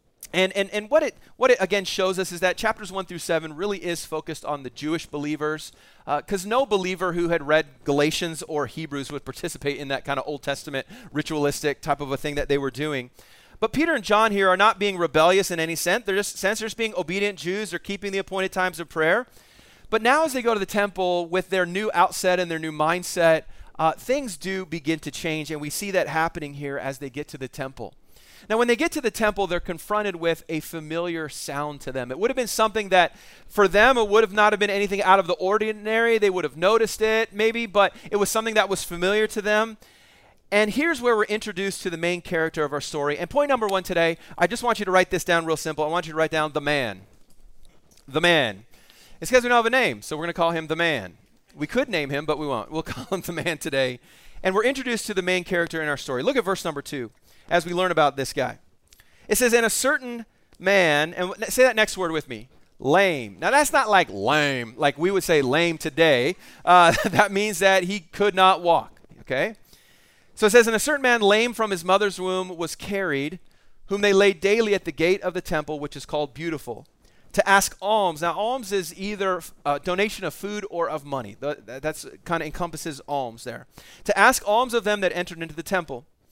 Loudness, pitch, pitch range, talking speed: -23 LUFS, 180 Hz, 155-205 Hz, 235 wpm